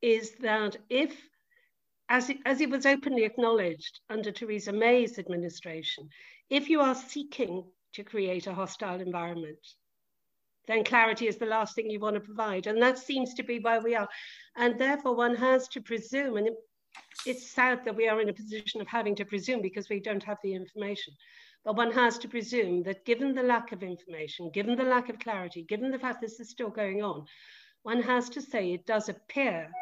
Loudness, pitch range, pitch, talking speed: -30 LUFS, 205-250 Hz, 225 Hz, 195 wpm